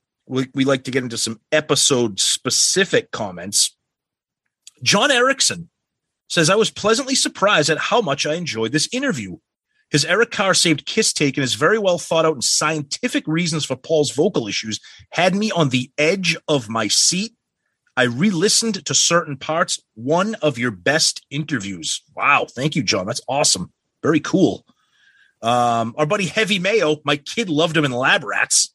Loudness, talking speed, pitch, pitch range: -18 LUFS, 170 wpm, 155 Hz, 135-195 Hz